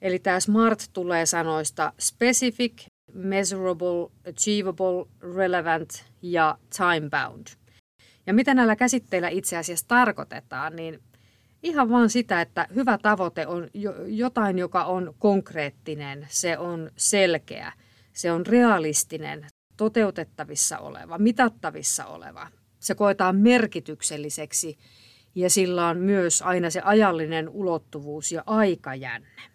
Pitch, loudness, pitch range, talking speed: 175 Hz, -24 LUFS, 155-205 Hz, 110 wpm